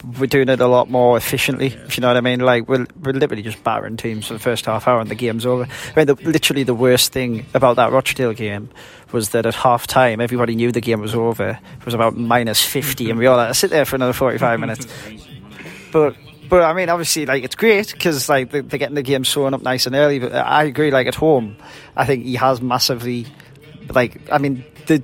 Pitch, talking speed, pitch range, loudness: 130 Hz, 245 wpm, 120-140 Hz, -17 LUFS